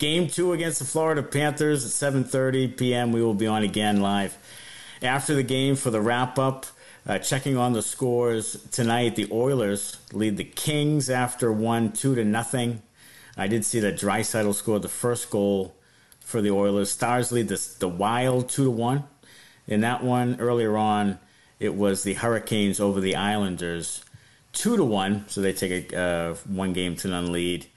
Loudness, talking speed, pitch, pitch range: -25 LUFS, 180 wpm, 115 Hz, 100-130 Hz